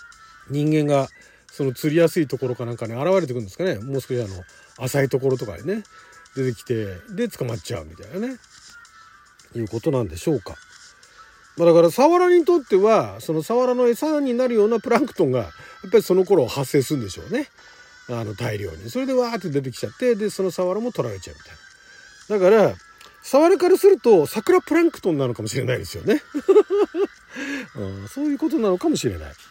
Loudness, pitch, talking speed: -21 LUFS, 180 Hz, 375 characters per minute